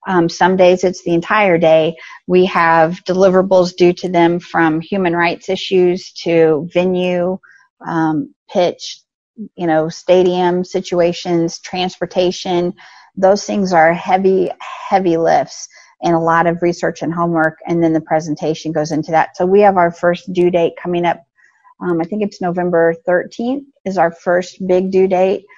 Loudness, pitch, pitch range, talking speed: -15 LUFS, 175 Hz, 165-185 Hz, 155 wpm